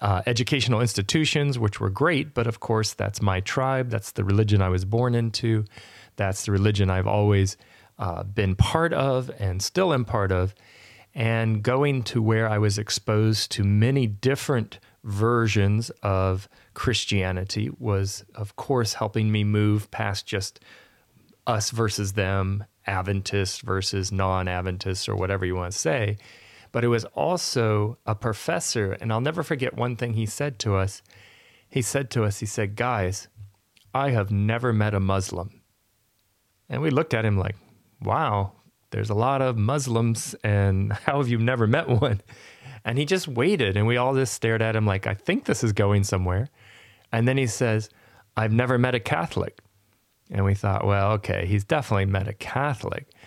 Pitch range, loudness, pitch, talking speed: 100-120 Hz, -25 LUFS, 110 Hz, 170 wpm